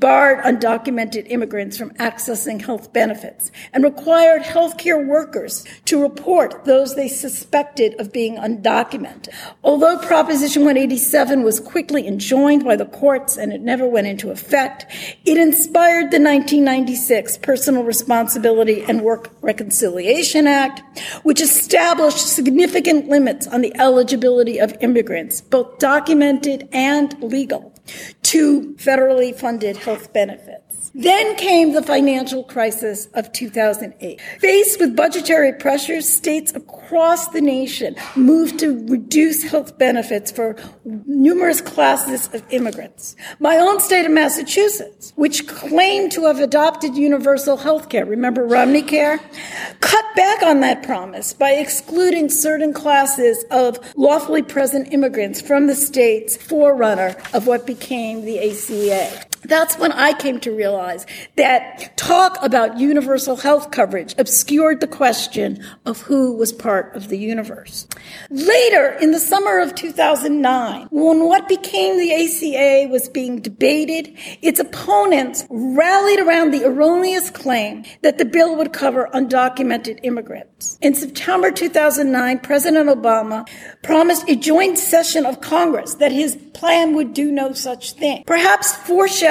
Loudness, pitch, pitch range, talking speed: -16 LUFS, 280 Hz, 245-315 Hz, 130 wpm